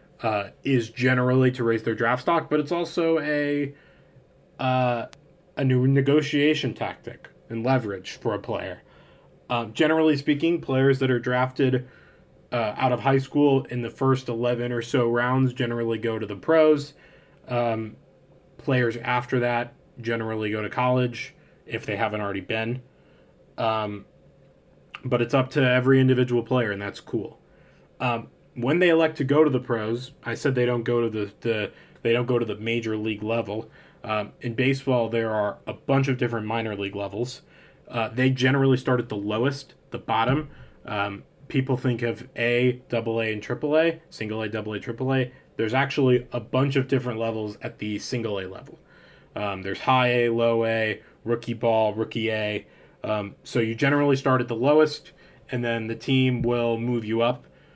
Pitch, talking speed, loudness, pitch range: 120 Hz, 175 wpm, -25 LUFS, 115-135 Hz